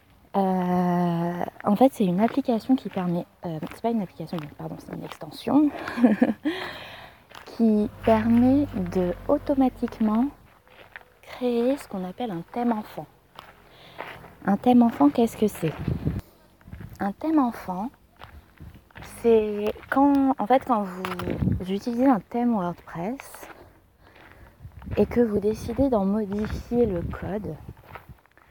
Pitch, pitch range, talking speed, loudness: 225 Hz, 185-250 Hz, 115 wpm, -24 LUFS